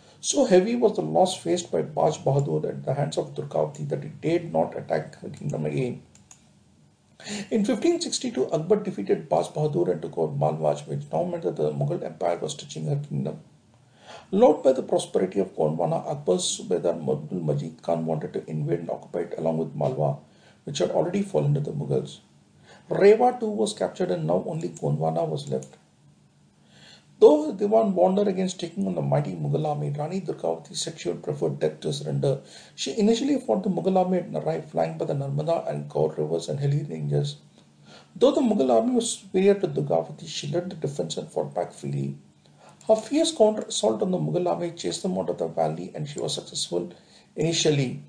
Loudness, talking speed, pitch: -25 LUFS, 190 wpm, 155 Hz